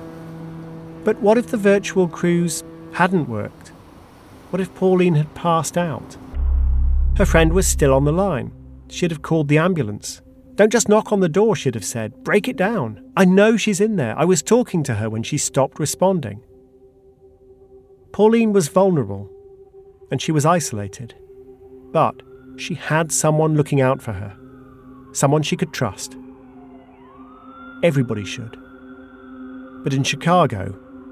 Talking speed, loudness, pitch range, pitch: 145 wpm, -19 LUFS, 130-180 Hz, 140 Hz